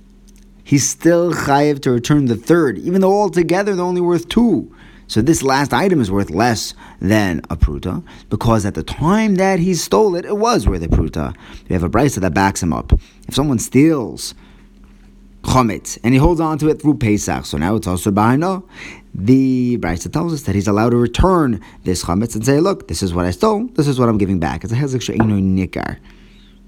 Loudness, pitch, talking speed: -16 LUFS, 120 Hz, 205 wpm